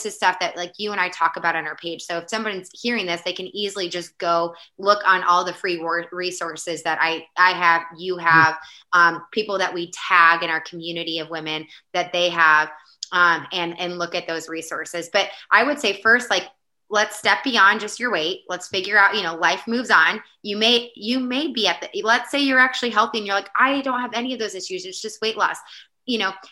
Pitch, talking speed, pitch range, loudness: 180 Hz, 235 wpm, 170-210 Hz, -20 LUFS